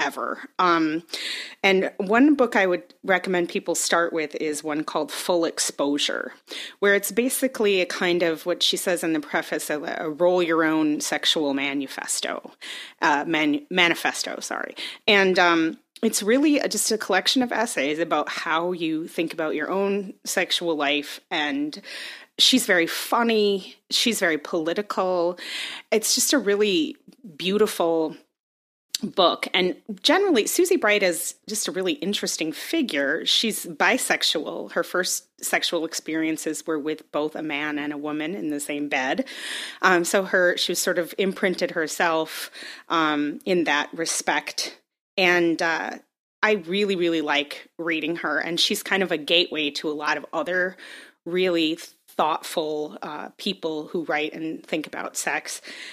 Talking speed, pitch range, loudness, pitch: 150 wpm, 160-205 Hz, -23 LUFS, 180 Hz